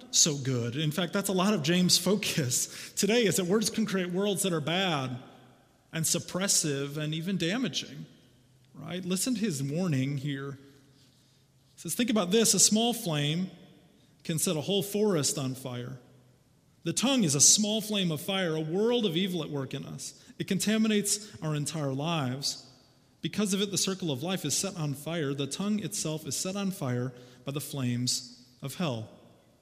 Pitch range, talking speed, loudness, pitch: 135-195 Hz, 180 wpm, -28 LUFS, 160 Hz